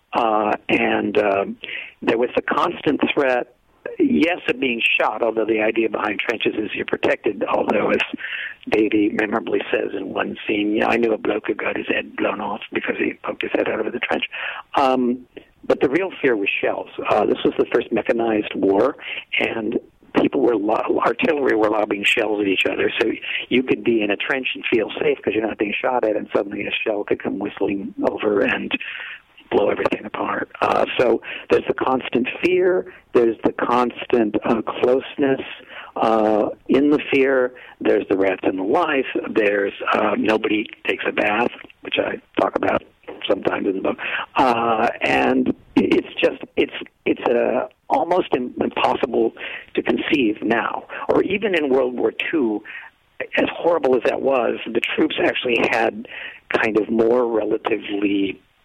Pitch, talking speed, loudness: 130 Hz, 170 wpm, -20 LUFS